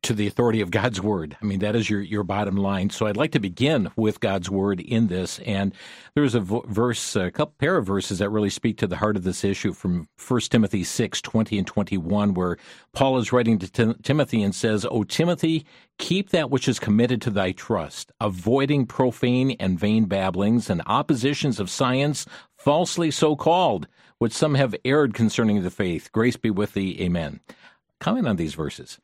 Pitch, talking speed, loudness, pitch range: 110 Hz, 205 wpm, -23 LUFS, 100-130 Hz